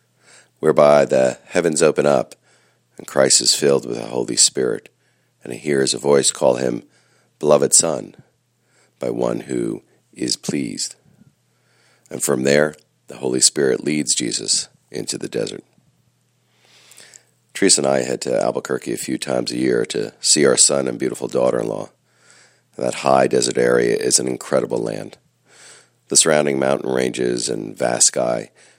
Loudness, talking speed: -18 LUFS, 150 wpm